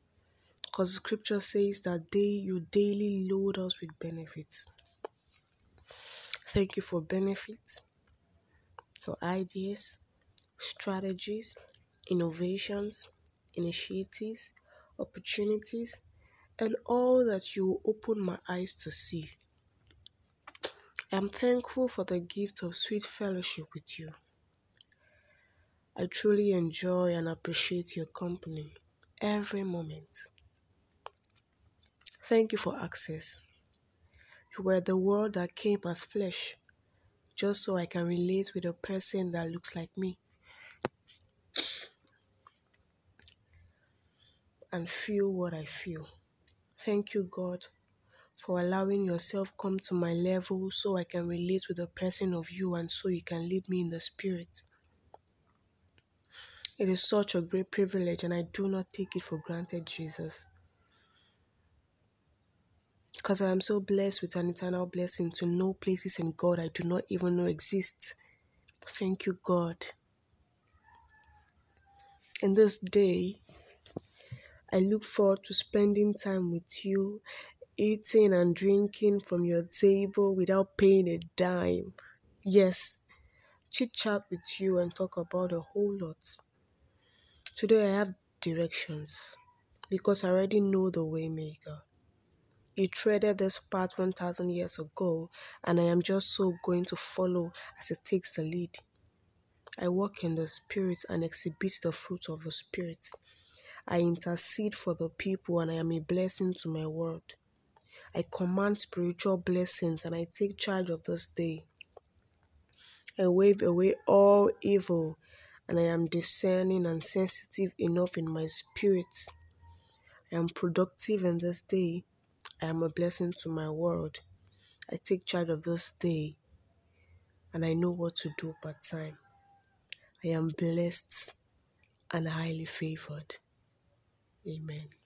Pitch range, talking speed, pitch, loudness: 160-195 Hz, 130 wpm, 180 Hz, -30 LUFS